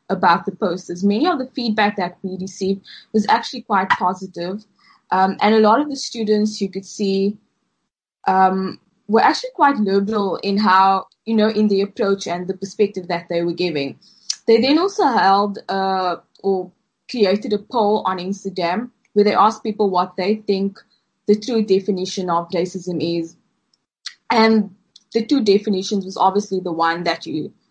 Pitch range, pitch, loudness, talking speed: 185-215 Hz, 195 Hz, -19 LUFS, 165 wpm